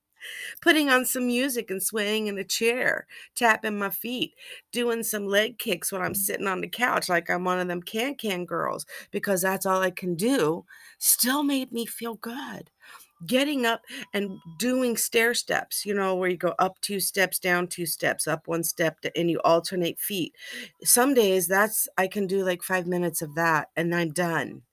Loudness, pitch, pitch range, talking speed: -25 LUFS, 195 Hz, 180-235 Hz, 190 wpm